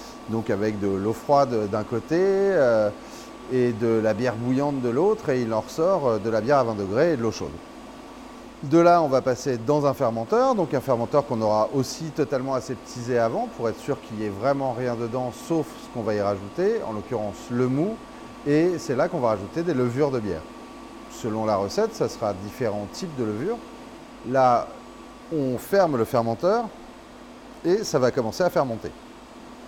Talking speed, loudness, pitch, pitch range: 190 wpm, -24 LUFS, 125 Hz, 110-145 Hz